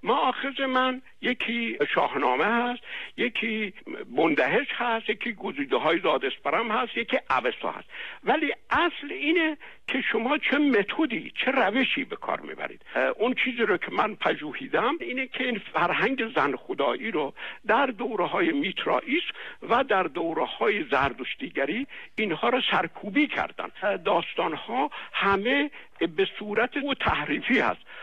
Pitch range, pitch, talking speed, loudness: 225-285 Hz, 255 Hz, 135 wpm, -26 LUFS